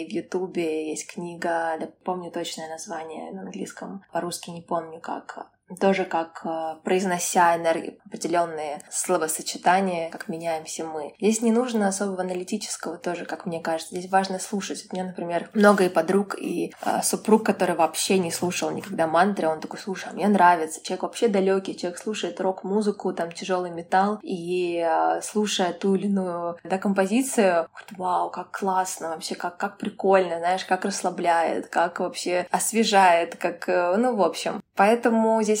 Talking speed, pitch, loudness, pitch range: 160 wpm, 180 Hz, -24 LUFS, 170-200 Hz